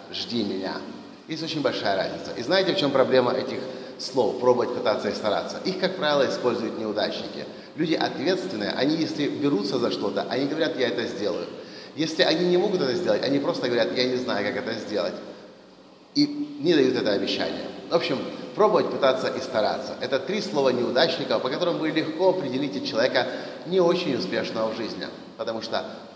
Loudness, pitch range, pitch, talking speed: -25 LUFS, 125-180 Hz, 155 Hz, 175 wpm